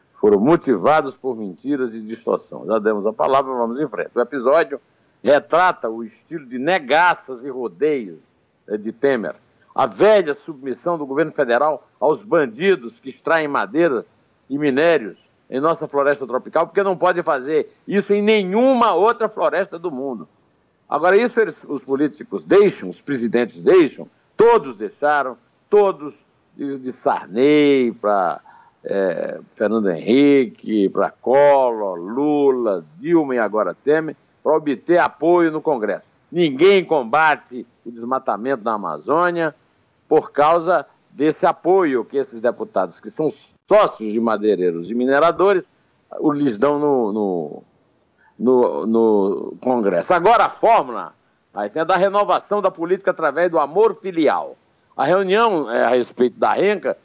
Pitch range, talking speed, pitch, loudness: 125-180 Hz, 135 wpm, 145 Hz, -18 LUFS